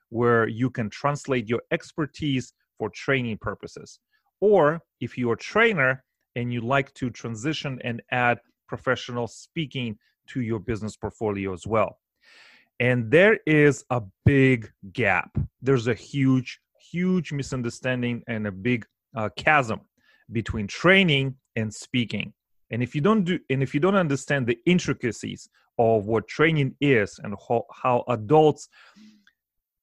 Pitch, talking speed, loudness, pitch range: 125 Hz, 140 wpm, -24 LUFS, 115-145 Hz